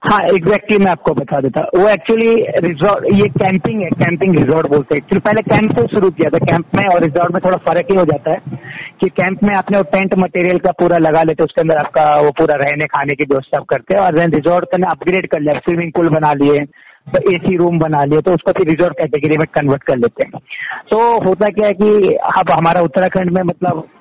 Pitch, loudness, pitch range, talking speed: 175 Hz, -13 LUFS, 155-190 Hz, 230 wpm